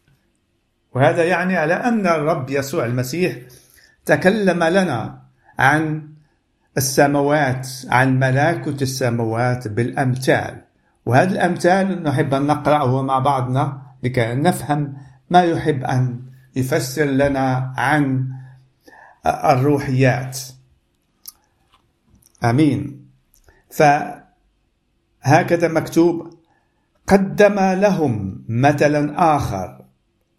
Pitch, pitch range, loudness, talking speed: 140 Hz, 125-160 Hz, -18 LUFS, 75 wpm